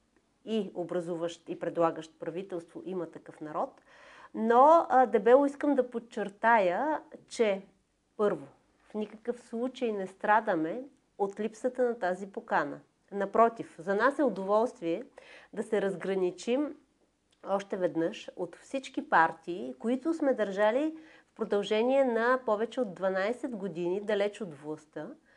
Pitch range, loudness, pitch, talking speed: 180-255 Hz, -30 LUFS, 215 Hz, 120 wpm